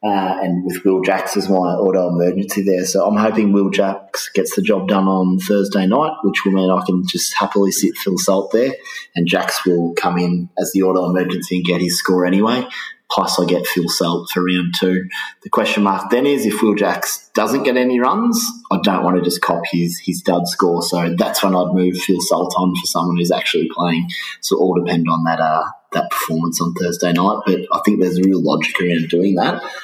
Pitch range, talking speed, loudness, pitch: 90-95 Hz, 225 wpm, -17 LUFS, 90 Hz